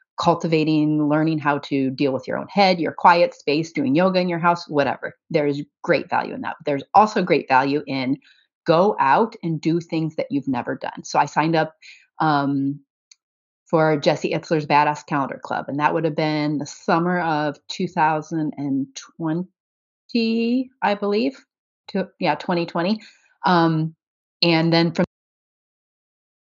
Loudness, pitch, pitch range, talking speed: -21 LUFS, 160 Hz, 150-180 Hz, 150 wpm